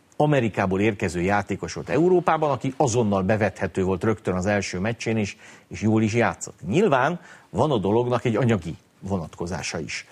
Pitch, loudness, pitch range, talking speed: 110 Hz, -23 LUFS, 95-120 Hz, 155 wpm